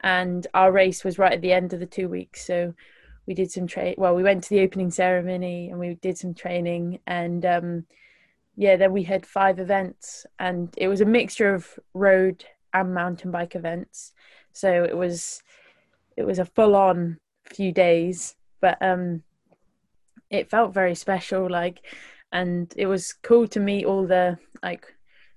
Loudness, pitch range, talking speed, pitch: -23 LUFS, 175-195 Hz, 175 wpm, 185 Hz